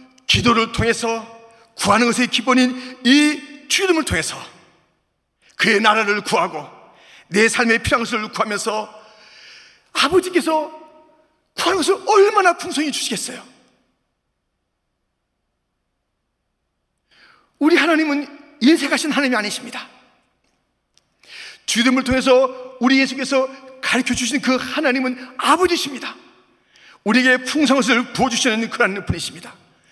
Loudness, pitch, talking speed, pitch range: -17 LUFS, 260 Hz, 260 characters per minute, 235-295 Hz